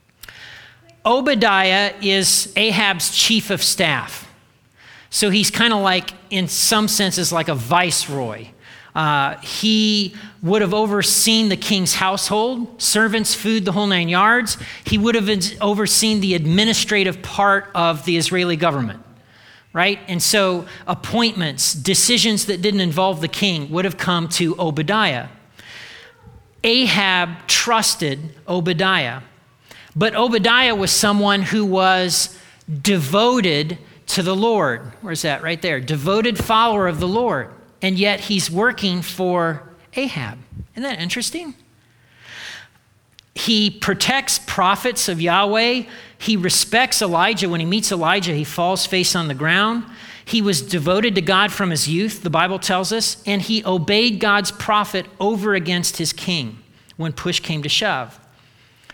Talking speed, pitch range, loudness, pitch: 135 wpm, 170-210 Hz, -17 LUFS, 190 Hz